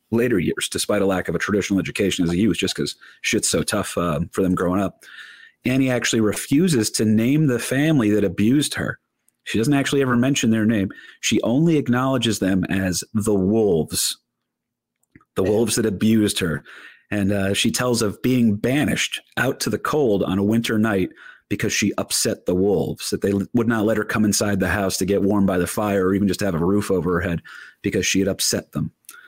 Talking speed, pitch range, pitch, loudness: 205 wpm, 95-115 Hz, 105 Hz, -20 LUFS